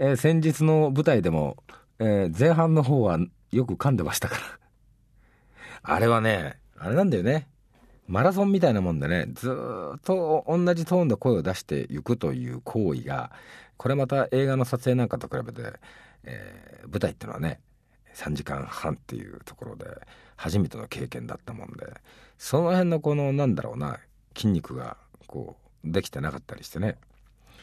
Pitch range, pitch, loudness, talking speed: 100-150 Hz, 125 Hz, -26 LUFS, 325 characters per minute